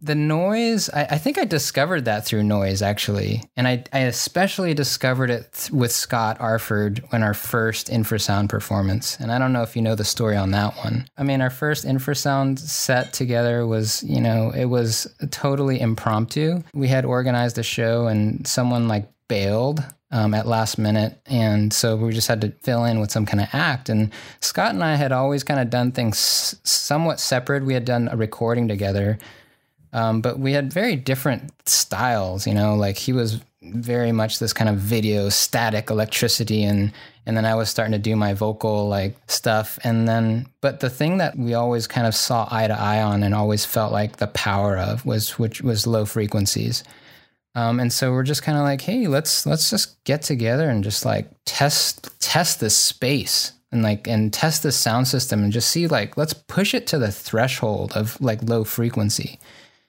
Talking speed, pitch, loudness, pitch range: 200 wpm, 115 Hz, -21 LUFS, 110-135 Hz